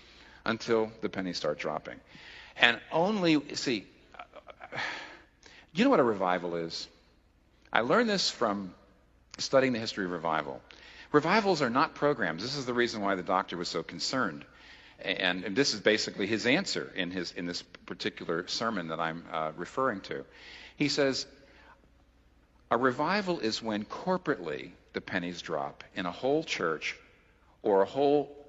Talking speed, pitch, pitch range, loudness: 150 wpm, 105 Hz, 90-140 Hz, -30 LUFS